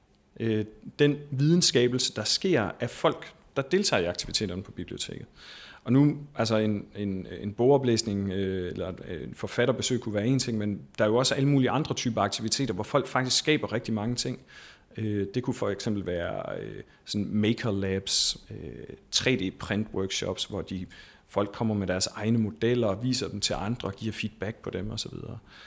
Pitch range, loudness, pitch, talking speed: 105-130 Hz, -28 LUFS, 110 Hz, 175 wpm